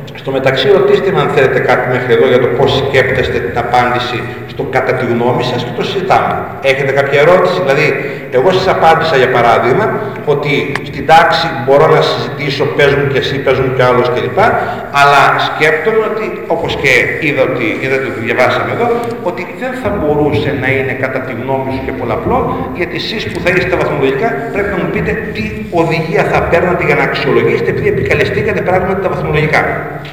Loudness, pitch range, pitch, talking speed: -12 LUFS, 130-185 Hz, 145 Hz, 180 wpm